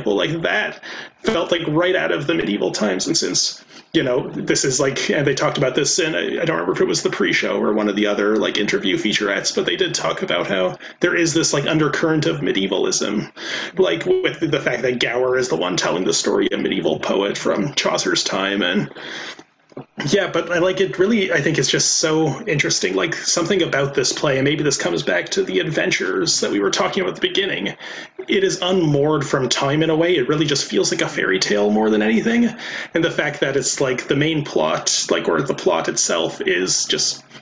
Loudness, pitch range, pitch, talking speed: -18 LUFS, 130-180 Hz, 160 Hz, 225 wpm